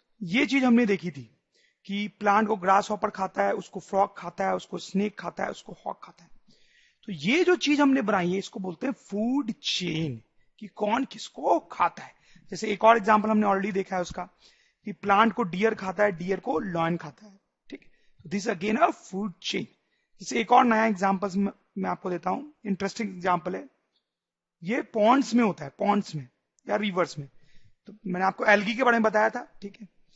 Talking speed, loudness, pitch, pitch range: 205 wpm, -26 LUFS, 205 Hz, 185-225 Hz